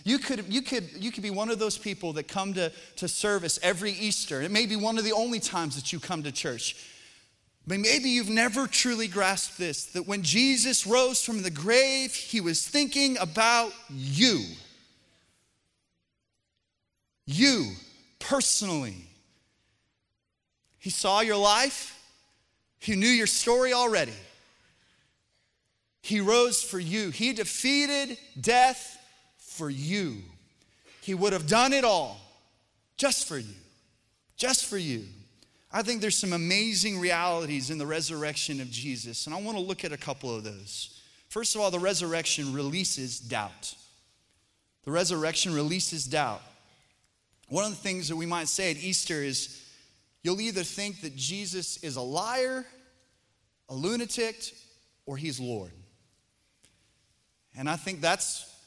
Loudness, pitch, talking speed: -27 LUFS, 175 Hz, 145 wpm